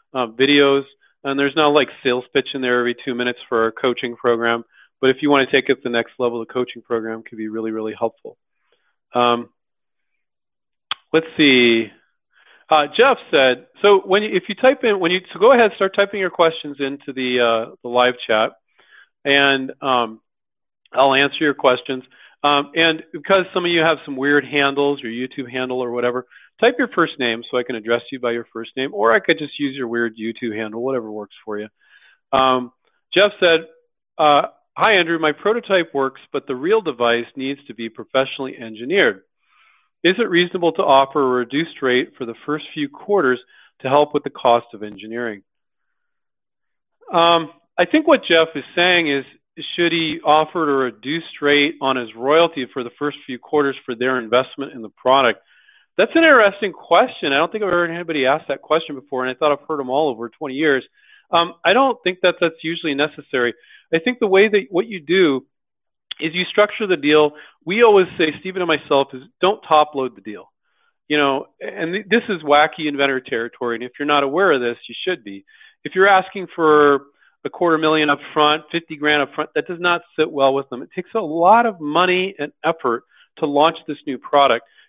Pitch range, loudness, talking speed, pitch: 125-170 Hz, -18 LUFS, 200 wpm, 145 Hz